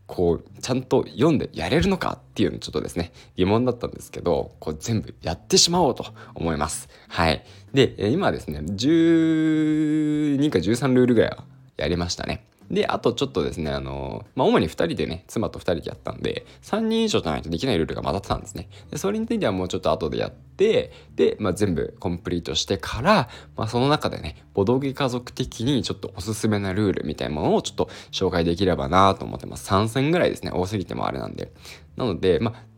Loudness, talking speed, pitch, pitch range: -23 LUFS, 435 characters per minute, 110 Hz, 90-145 Hz